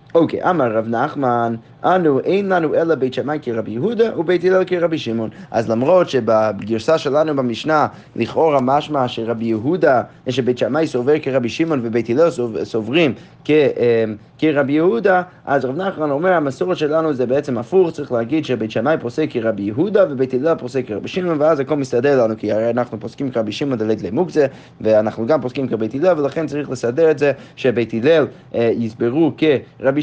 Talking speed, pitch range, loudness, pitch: 170 wpm, 115-155 Hz, -18 LUFS, 135 Hz